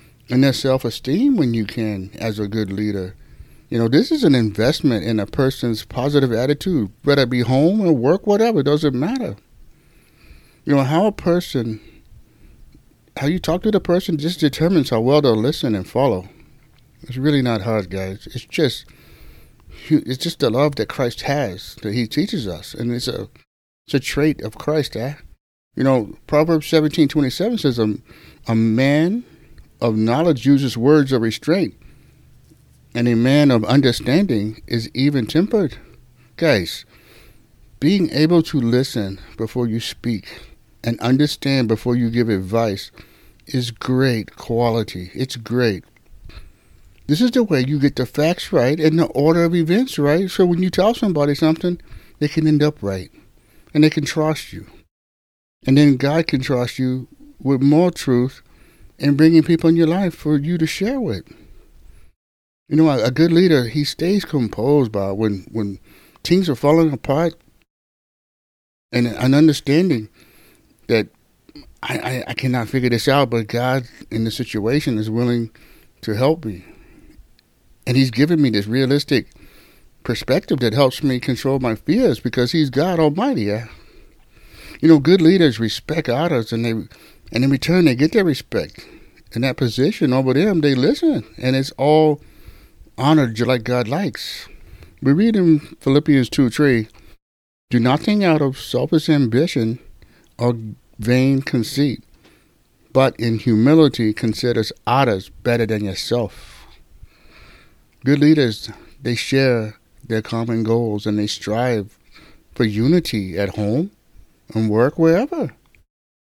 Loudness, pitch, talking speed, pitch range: -18 LUFS, 130 Hz, 150 wpm, 110-150 Hz